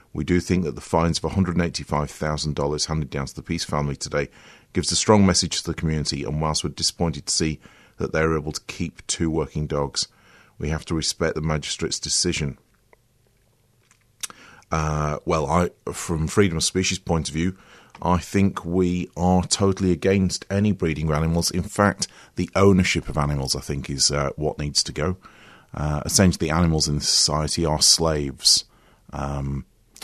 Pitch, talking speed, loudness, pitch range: 80 Hz, 170 wpm, -22 LUFS, 75-90 Hz